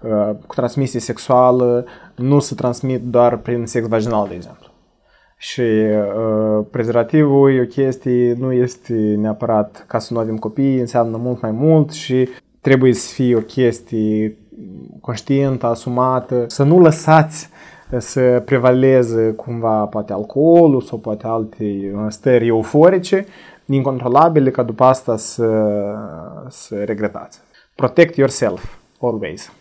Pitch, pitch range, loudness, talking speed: 125 Hz, 110-135 Hz, -16 LUFS, 125 wpm